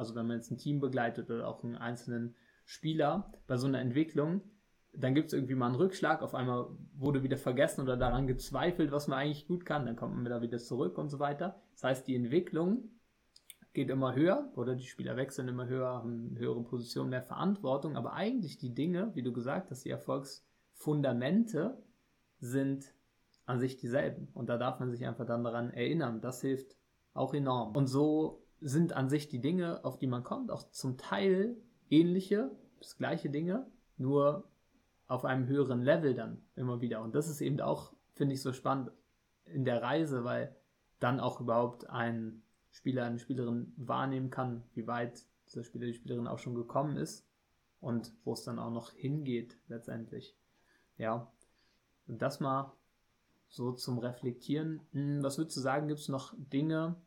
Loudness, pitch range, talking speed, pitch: -35 LUFS, 120-150 Hz, 180 wpm, 130 Hz